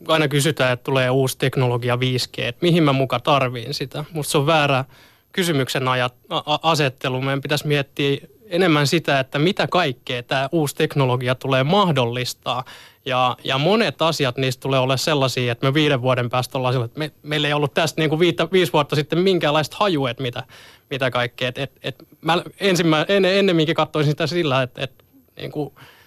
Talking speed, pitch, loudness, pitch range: 185 wpm, 140 Hz, -20 LUFS, 130-160 Hz